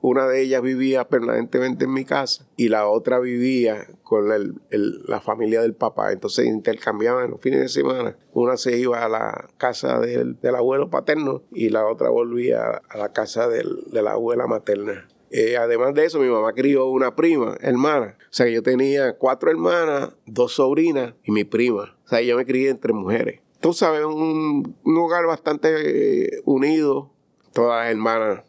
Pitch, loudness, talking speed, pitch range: 130 Hz, -21 LUFS, 180 wpm, 120-160 Hz